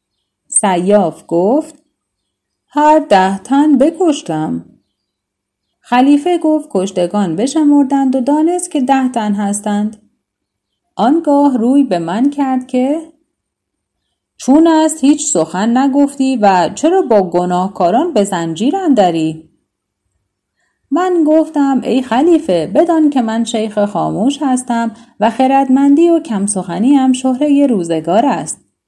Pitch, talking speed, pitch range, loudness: 255 Hz, 110 wpm, 190-290 Hz, -12 LUFS